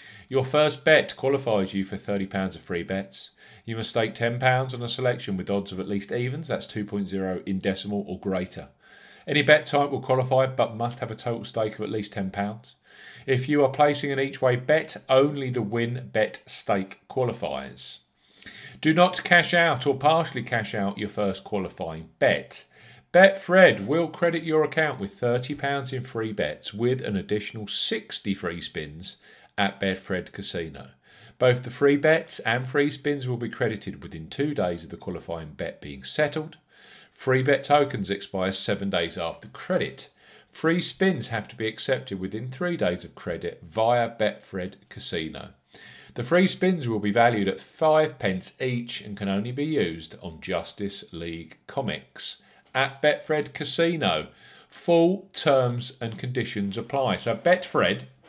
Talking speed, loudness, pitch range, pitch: 165 wpm, -25 LUFS, 100-145 Hz, 120 Hz